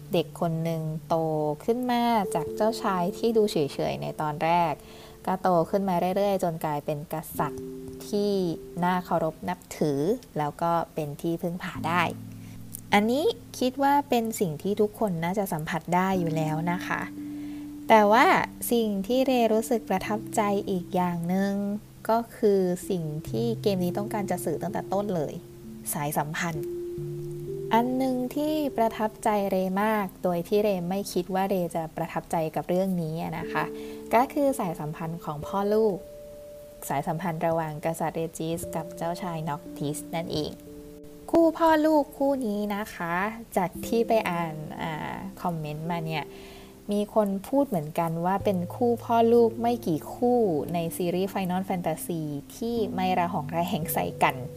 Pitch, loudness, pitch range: 180 Hz, -27 LUFS, 160-215 Hz